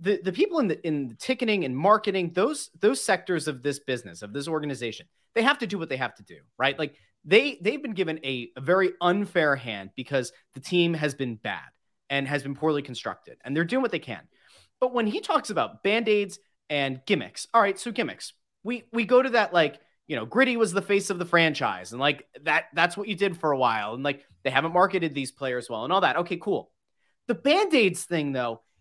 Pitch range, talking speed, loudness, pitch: 140-210 Hz, 230 wpm, -26 LUFS, 175 Hz